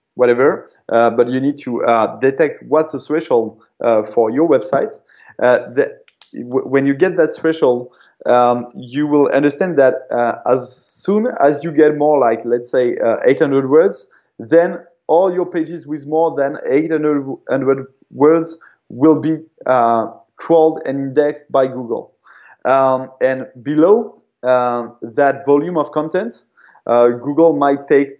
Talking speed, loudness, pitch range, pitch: 150 wpm, -15 LUFS, 130-160 Hz, 145 Hz